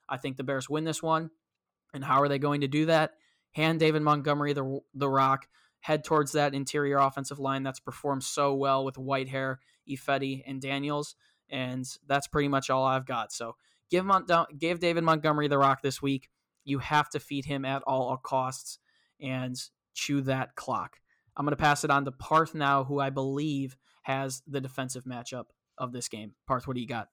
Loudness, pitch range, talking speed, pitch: -29 LUFS, 135-150 Hz, 195 wpm, 140 Hz